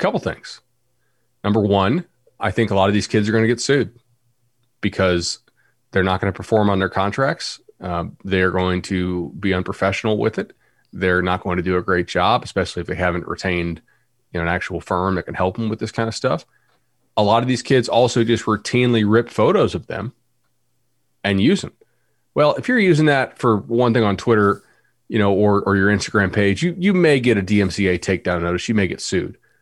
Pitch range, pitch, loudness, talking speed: 95-120 Hz, 105 Hz, -19 LUFS, 210 wpm